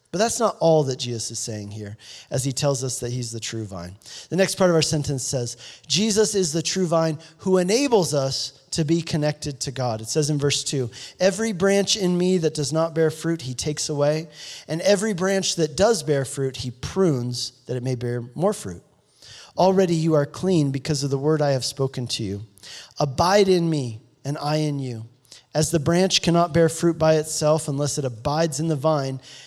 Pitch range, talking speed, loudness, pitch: 130-170 Hz, 210 wpm, -22 LUFS, 150 Hz